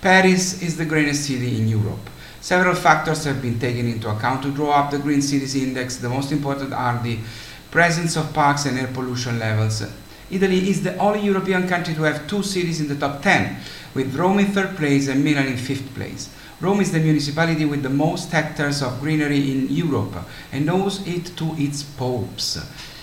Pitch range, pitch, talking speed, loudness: 130-170 Hz, 145 Hz, 195 wpm, -21 LUFS